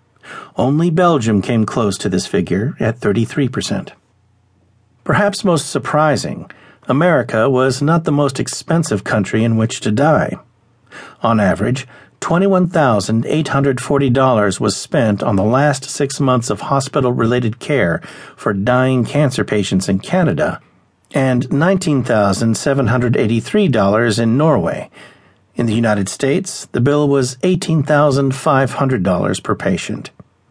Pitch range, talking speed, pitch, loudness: 110-145 Hz, 110 wpm, 130 Hz, -15 LUFS